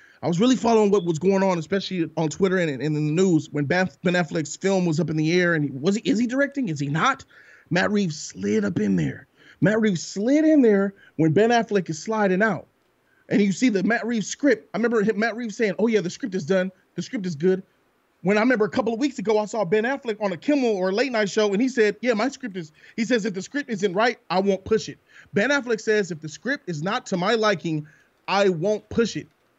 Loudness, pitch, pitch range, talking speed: -23 LUFS, 200 Hz, 175-225 Hz, 255 wpm